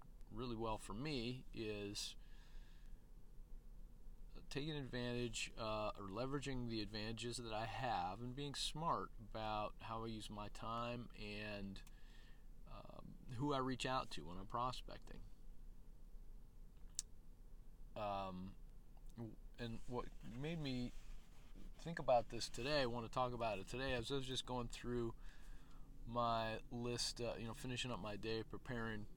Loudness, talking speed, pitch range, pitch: -46 LUFS, 135 wpm, 110-130 Hz, 120 Hz